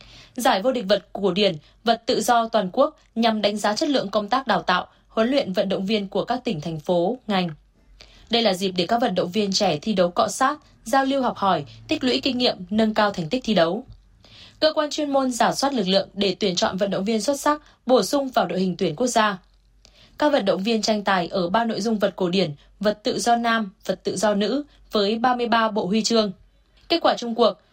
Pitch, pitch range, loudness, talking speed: 220 Hz, 195-245 Hz, -22 LUFS, 240 wpm